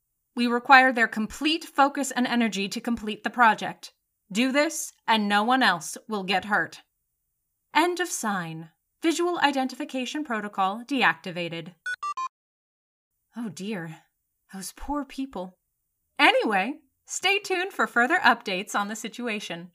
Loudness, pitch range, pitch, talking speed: -25 LUFS, 205-280 Hz, 235 Hz, 125 wpm